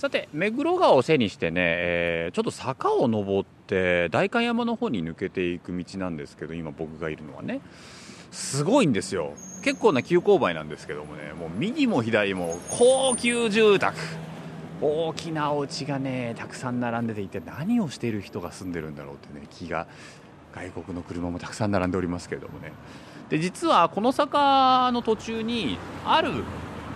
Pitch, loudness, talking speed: 115 Hz, -25 LUFS, 330 characters per minute